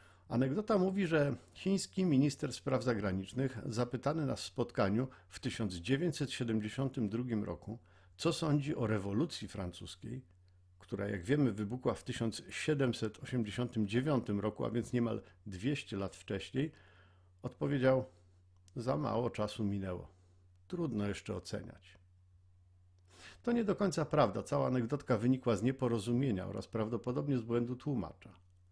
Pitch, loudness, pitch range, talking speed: 115 Hz, -36 LUFS, 95-130 Hz, 115 wpm